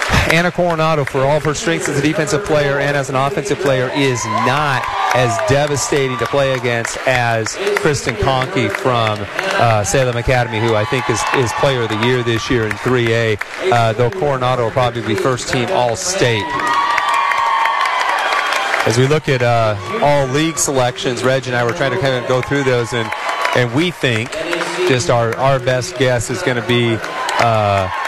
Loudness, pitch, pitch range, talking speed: -15 LUFS, 125 Hz, 115-140 Hz, 175 wpm